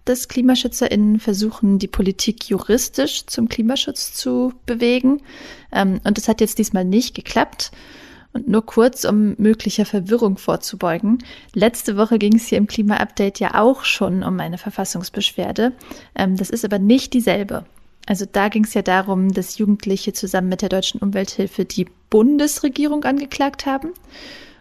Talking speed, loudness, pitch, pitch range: 145 wpm, -18 LUFS, 220 Hz, 200-250 Hz